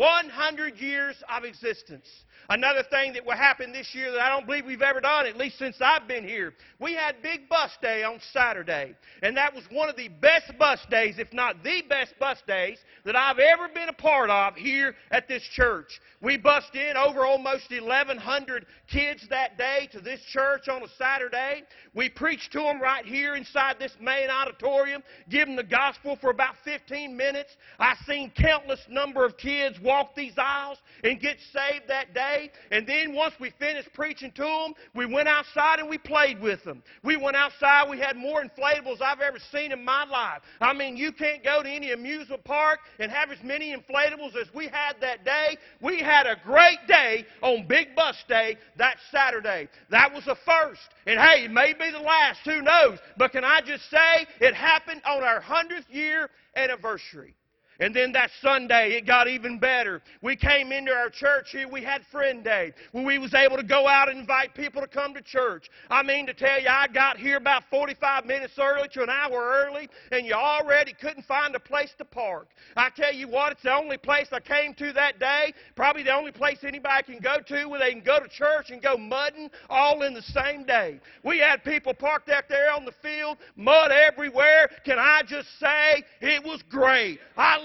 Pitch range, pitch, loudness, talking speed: 260-295 Hz, 275 Hz, -24 LUFS, 205 wpm